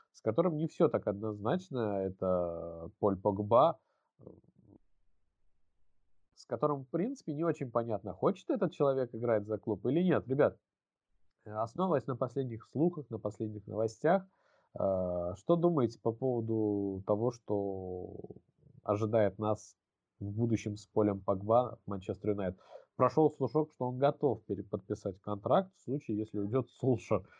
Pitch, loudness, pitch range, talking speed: 110 Hz, -33 LUFS, 100-135 Hz, 130 wpm